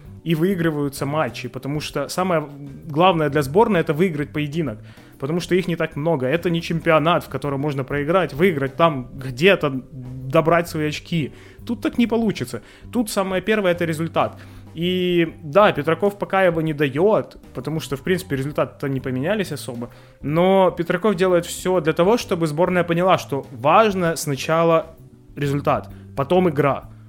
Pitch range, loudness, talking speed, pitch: 135-180 Hz, -20 LUFS, 155 wpm, 160 Hz